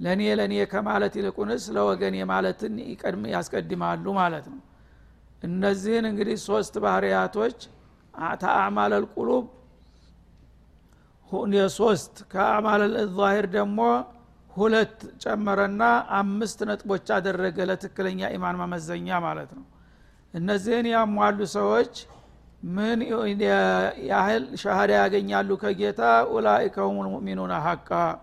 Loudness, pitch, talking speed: -25 LUFS, 195 Hz, 90 wpm